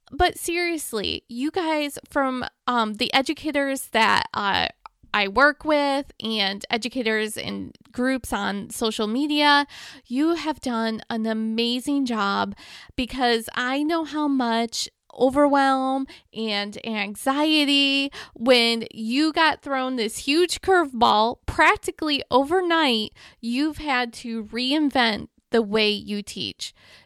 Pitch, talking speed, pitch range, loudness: 255 Hz, 115 wpm, 225-290 Hz, -23 LUFS